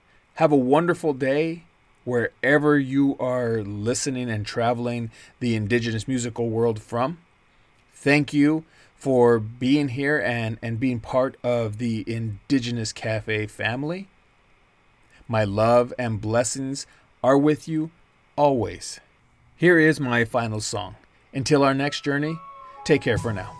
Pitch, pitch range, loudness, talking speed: 125 Hz, 115-145 Hz, -23 LUFS, 125 wpm